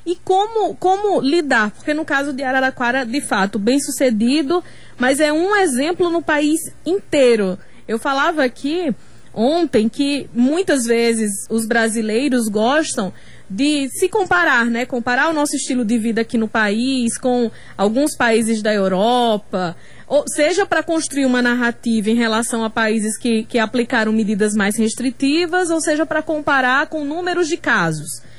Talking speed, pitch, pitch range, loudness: 150 wpm, 255 Hz, 225-310 Hz, -17 LUFS